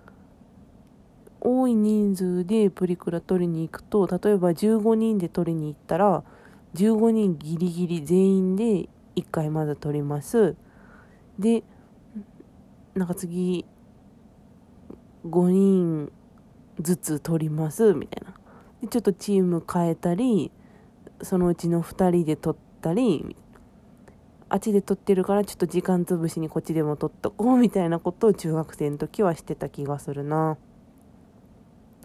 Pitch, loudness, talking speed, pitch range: 180 Hz, -24 LUFS, 245 characters per minute, 165-210 Hz